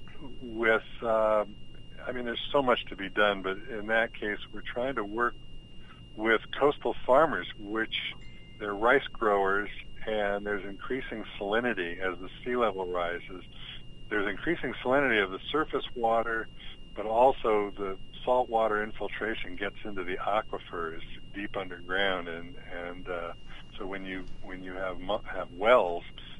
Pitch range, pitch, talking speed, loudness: 95-115 Hz, 105 Hz, 145 wpm, -30 LUFS